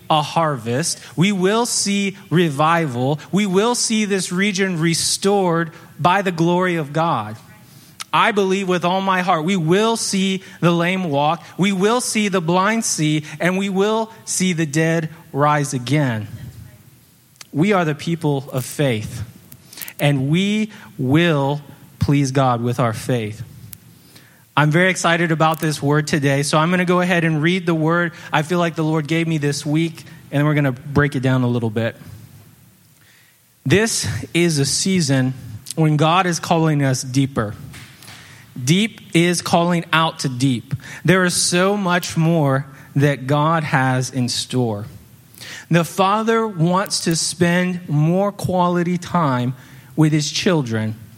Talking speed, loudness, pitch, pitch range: 150 wpm, -18 LUFS, 160 Hz, 140-180 Hz